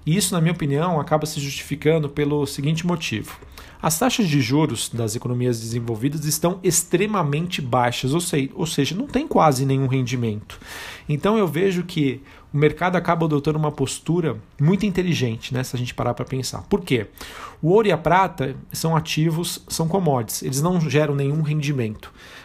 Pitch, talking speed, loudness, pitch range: 150 Hz, 170 wpm, -21 LUFS, 130-170 Hz